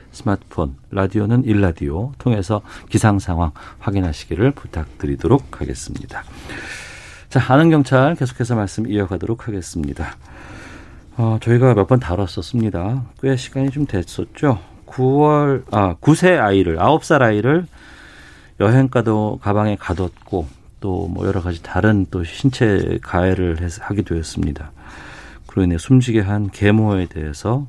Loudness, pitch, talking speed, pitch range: -18 LUFS, 105 Hz, 285 characters per minute, 90-125 Hz